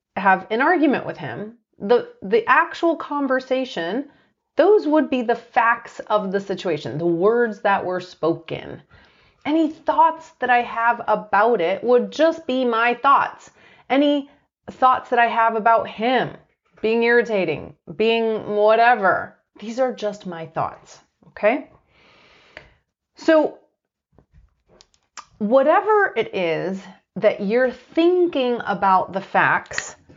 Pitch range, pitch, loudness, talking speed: 200-280 Hz, 235 Hz, -20 LUFS, 120 wpm